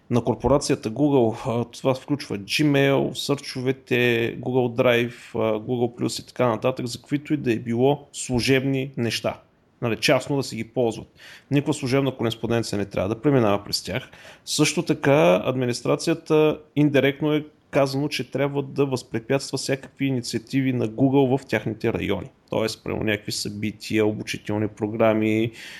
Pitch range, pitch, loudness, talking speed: 115-140 Hz, 130 Hz, -23 LUFS, 140 wpm